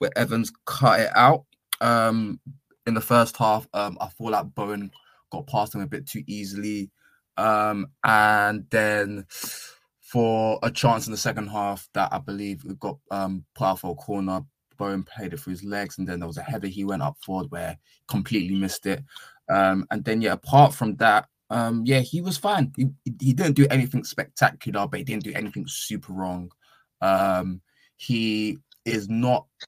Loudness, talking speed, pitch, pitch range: -24 LUFS, 185 wpm, 105 Hz, 95-120 Hz